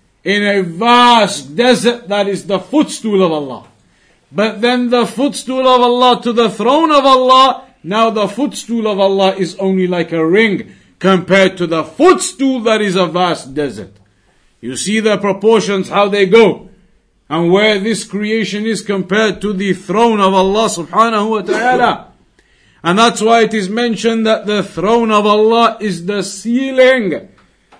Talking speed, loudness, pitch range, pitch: 160 wpm, -12 LUFS, 190-235 Hz, 210 Hz